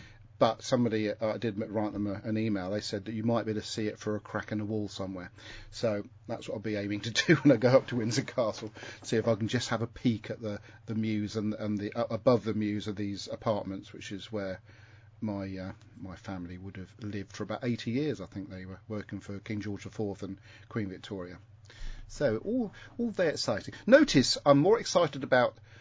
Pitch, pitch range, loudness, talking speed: 110 Hz, 105-115 Hz, -31 LUFS, 230 wpm